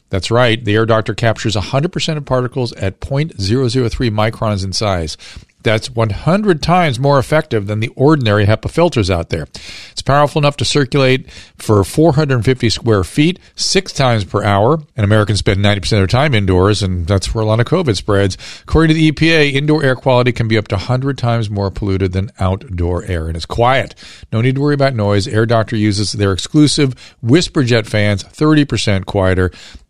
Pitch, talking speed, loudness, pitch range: 115 Hz, 185 wpm, -14 LUFS, 100-140 Hz